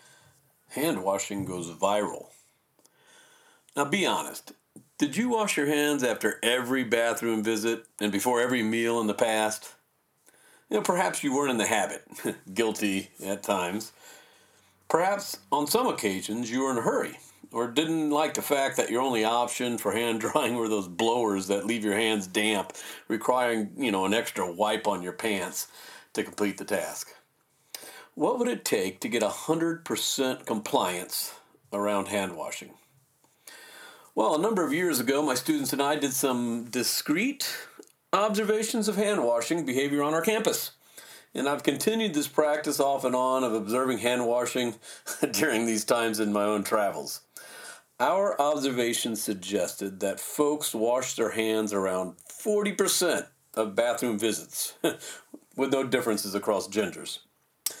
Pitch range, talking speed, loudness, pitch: 110-150 Hz, 150 wpm, -28 LUFS, 120 Hz